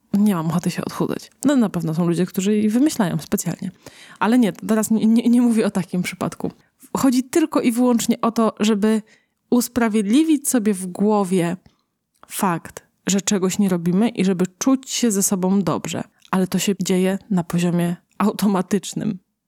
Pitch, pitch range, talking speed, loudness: 205 Hz, 185-230 Hz, 165 wpm, -20 LUFS